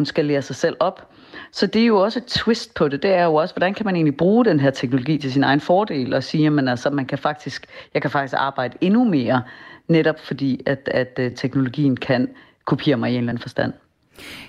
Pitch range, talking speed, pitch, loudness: 135-175 Hz, 235 wpm, 145 Hz, -20 LUFS